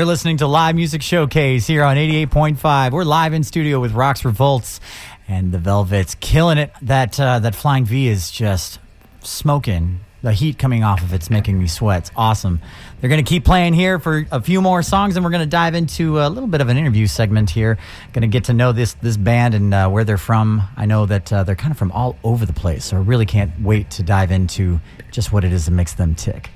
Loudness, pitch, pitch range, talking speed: -17 LUFS, 115 Hz, 100-150 Hz, 240 wpm